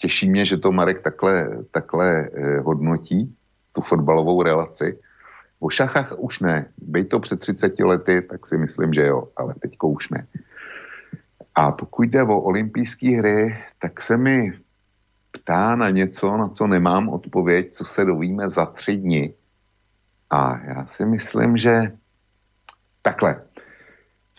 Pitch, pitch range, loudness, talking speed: 100 Hz, 90-105 Hz, -21 LUFS, 145 wpm